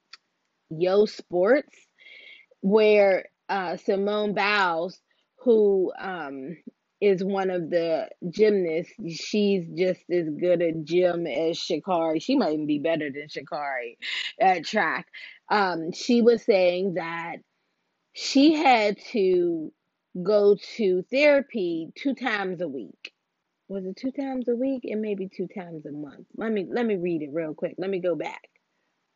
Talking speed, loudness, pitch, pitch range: 140 wpm, -25 LUFS, 190 Hz, 170-230 Hz